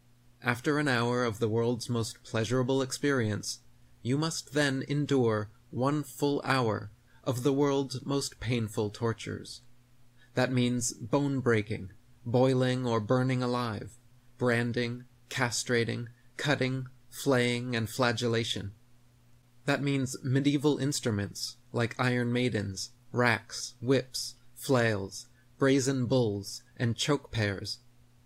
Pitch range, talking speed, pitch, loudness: 115-130 Hz, 110 wpm, 120 Hz, -30 LUFS